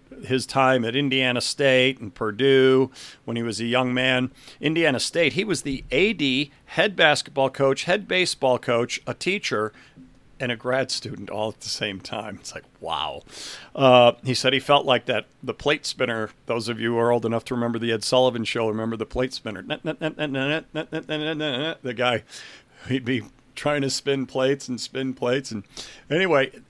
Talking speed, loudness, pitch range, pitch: 180 wpm, -23 LUFS, 120-140 Hz, 130 Hz